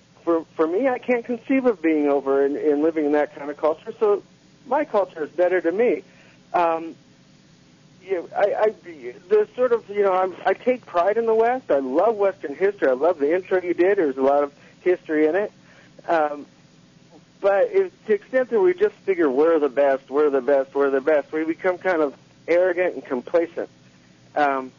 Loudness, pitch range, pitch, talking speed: -22 LUFS, 145-225 Hz, 170 Hz, 210 wpm